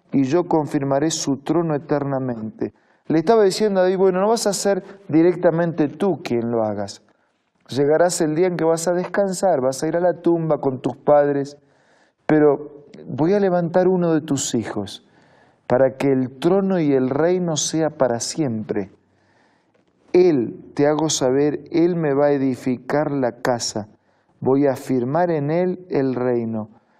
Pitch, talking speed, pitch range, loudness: 150 Hz, 165 wpm, 130-175 Hz, -20 LUFS